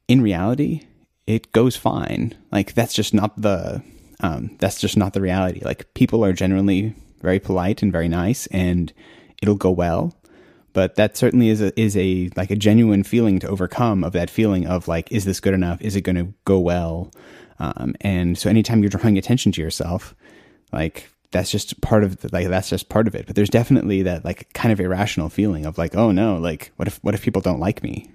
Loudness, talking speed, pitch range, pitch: -20 LUFS, 215 wpm, 90-110 Hz, 100 Hz